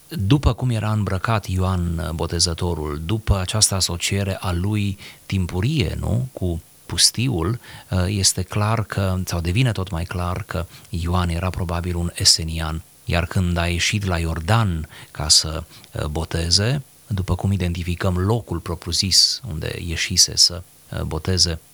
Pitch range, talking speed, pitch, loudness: 85-105 Hz, 130 wpm, 95 Hz, -20 LUFS